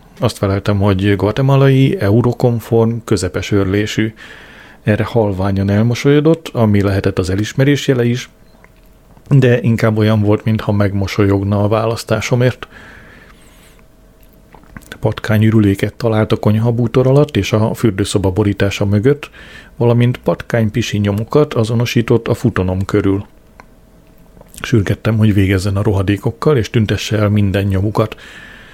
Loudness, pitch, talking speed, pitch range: -14 LUFS, 110 Hz, 110 wpm, 100-120 Hz